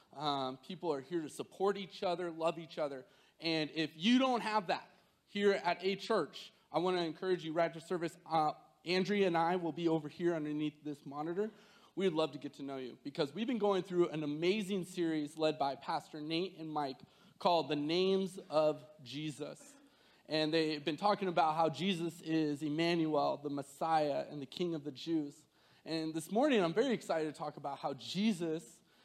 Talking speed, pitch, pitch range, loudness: 195 wpm, 165 Hz, 150-190 Hz, -36 LUFS